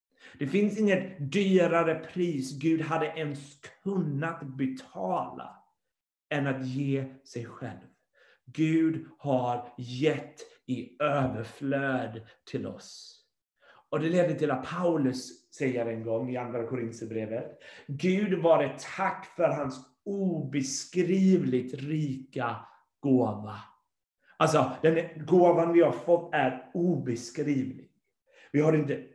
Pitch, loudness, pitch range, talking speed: 145 Hz, -29 LUFS, 130-165 Hz, 110 wpm